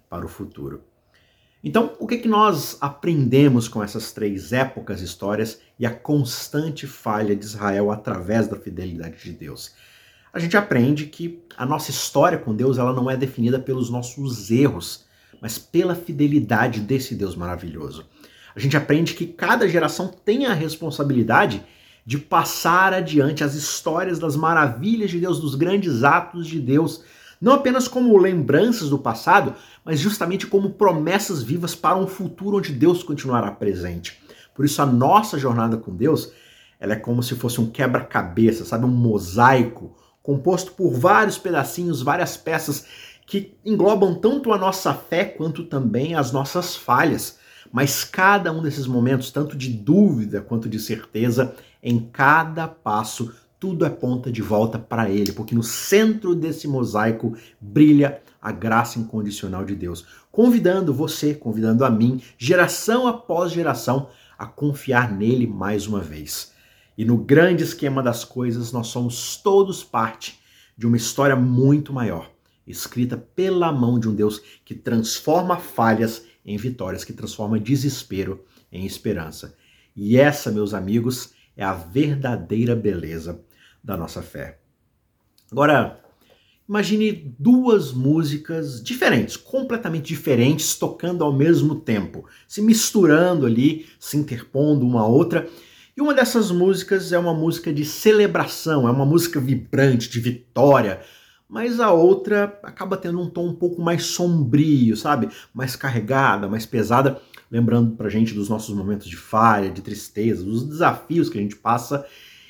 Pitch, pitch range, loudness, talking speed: 135 Hz, 115-170 Hz, -20 LUFS, 150 wpm